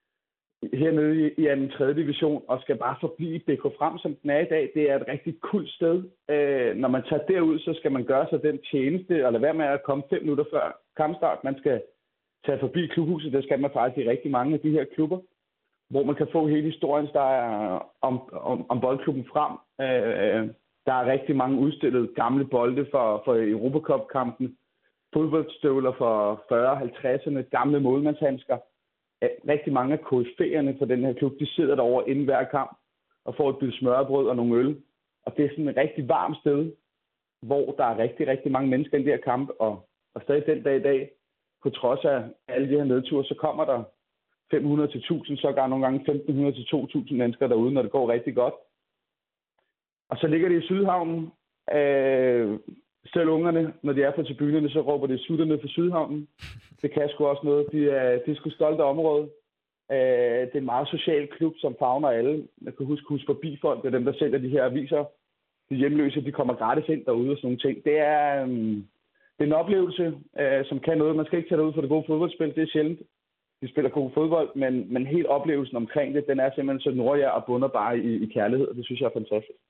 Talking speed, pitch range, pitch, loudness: 210 wpm, 130-155 Hz, 145 Hz, -25 LUFS